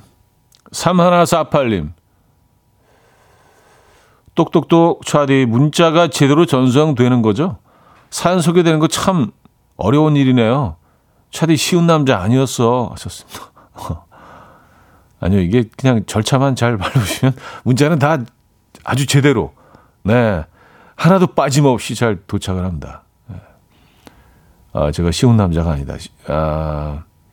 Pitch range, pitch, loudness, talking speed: 100-150 Hz, 125 Hz, -15 LUFS, 215 characters per minute